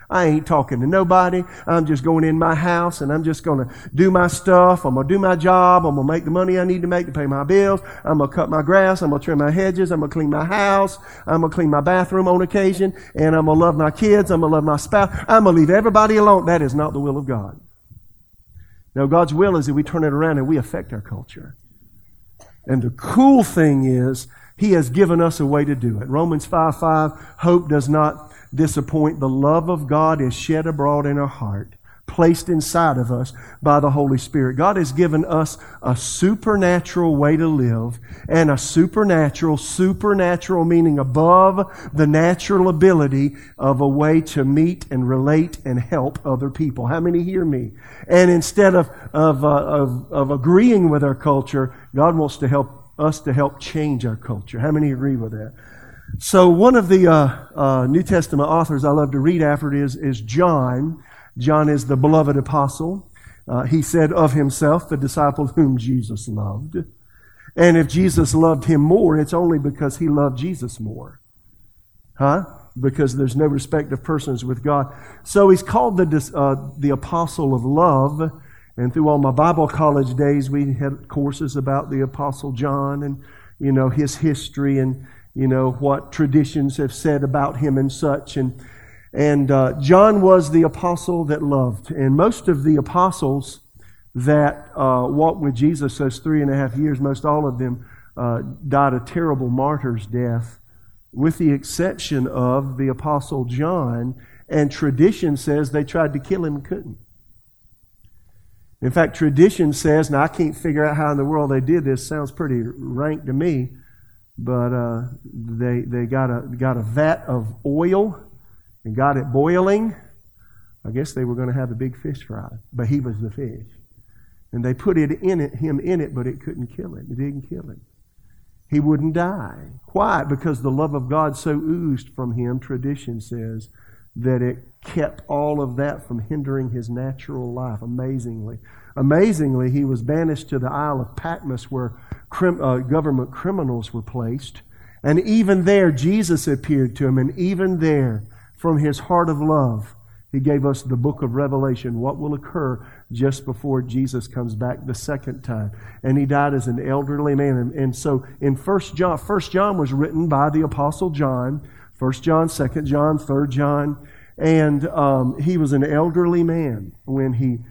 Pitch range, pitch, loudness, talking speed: 130-160 Hz, 145 Hz, -18 LUFS, 190 wpm